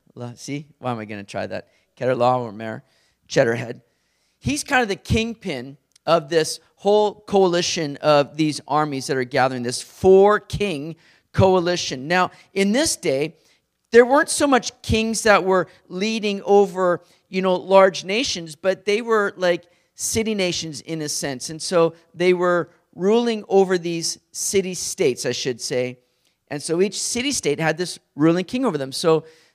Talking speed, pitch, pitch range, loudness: 160 wpm, 175 Hz, 150-200 Hz, -20 LUFS